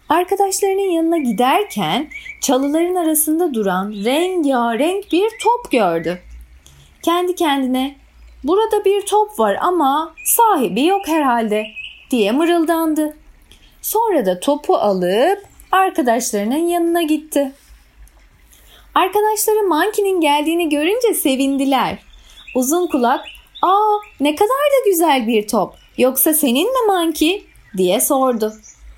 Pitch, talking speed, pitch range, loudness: 310 Hz, 100 wpm, 255-370 Hz, -16 LUFS